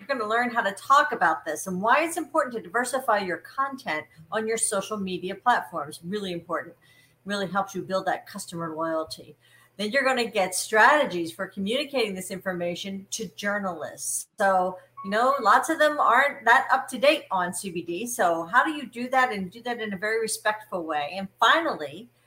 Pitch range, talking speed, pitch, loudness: 180-240 Hz, 195 wpm, 205 Hz, -25 LUFS